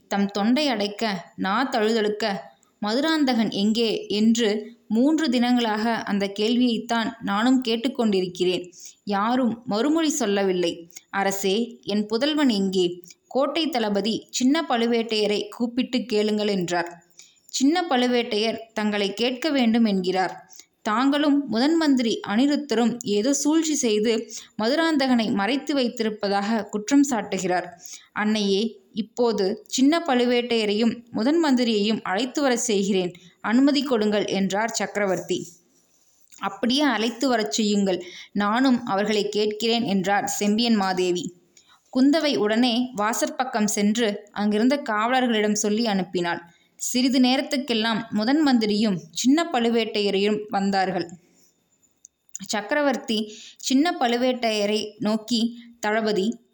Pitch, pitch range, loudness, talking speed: 220 Hz, 205-250 Hz, -23 LUFS, 95 wpm